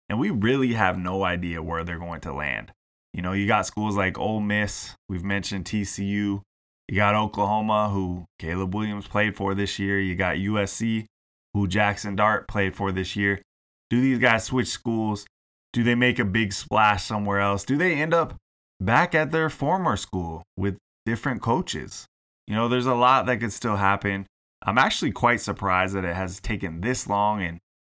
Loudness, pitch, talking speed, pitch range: -24 LUFS, 100 Hz, 190 wpm, 95-110 Hz